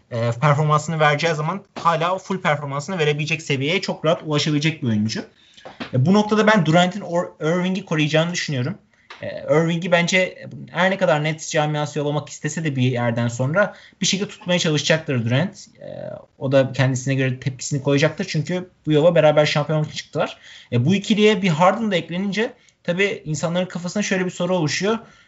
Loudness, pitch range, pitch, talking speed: -20 LUFS, 150-185 Hz, 160 Hz, 150 wpm